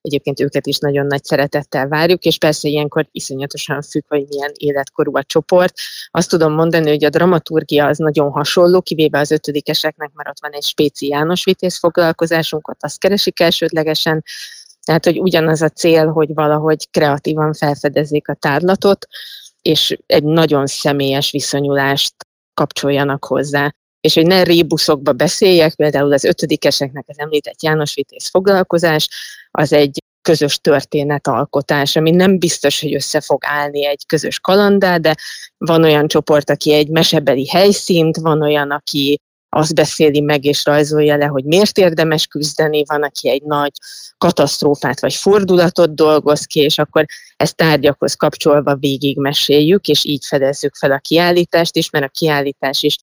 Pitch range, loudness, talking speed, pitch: 145-165 Hz, -14 LUFS, 150 wpm, 150 Hz